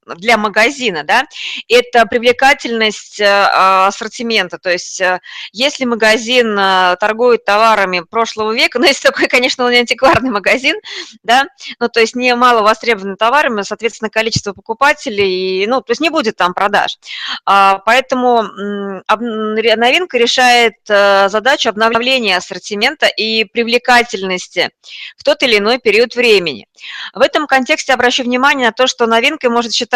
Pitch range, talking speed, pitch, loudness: 210-260 Hz, 130 wpm, 230 Hz, -12 LUFS